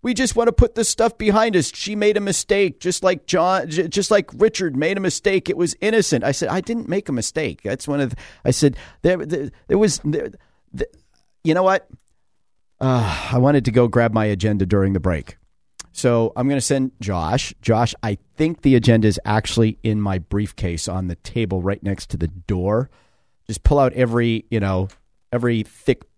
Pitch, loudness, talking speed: 125 Hz, -20 LUFS, 205 wpm